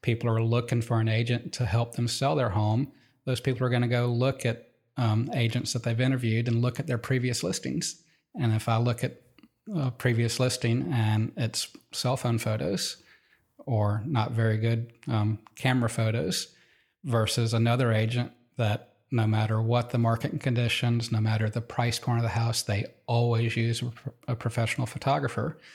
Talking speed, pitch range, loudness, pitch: 175 wpm, 115-125 Hz, -28 LUFS, 120 Hz